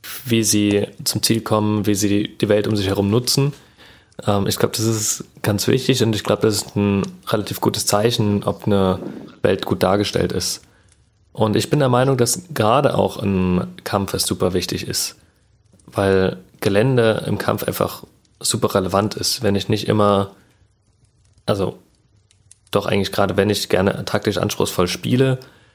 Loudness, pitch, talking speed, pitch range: -19 LUFS, 105 Hz, 165 wpm, 100-115 Hz